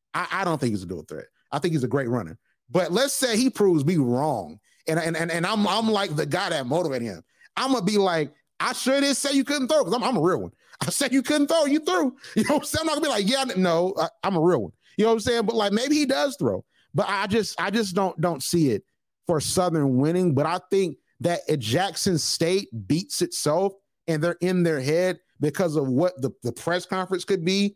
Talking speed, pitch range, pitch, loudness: 260 wpm, 165-235 Hz, 185 Hz, -24 LUFS